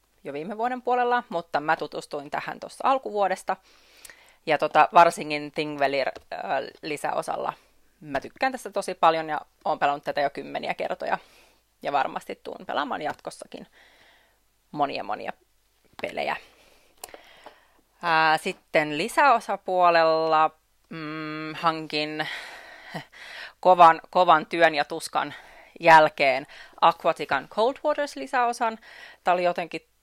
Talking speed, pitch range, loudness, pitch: 100 wpm, 155-225 Hz, -24 LUFS, 165 Hz